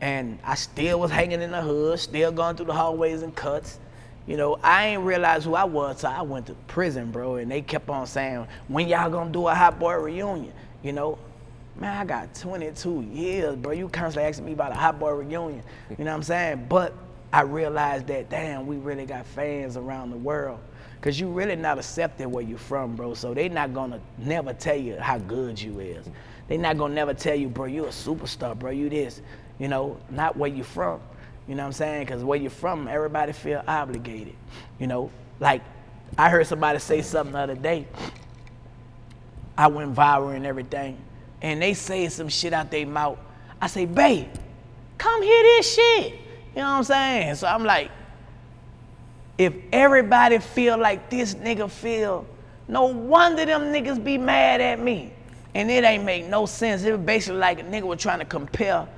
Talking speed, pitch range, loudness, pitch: 200 wpm, 125-175 Hz, -24 LUFS, 150 Hz